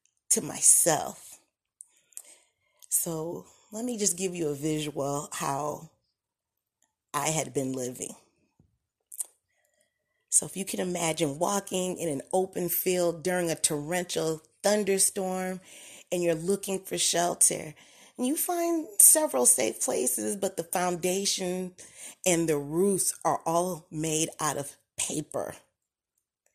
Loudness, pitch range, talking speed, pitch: -26 LUFS, 155-190 Hz, 120 wpm, 175 Hz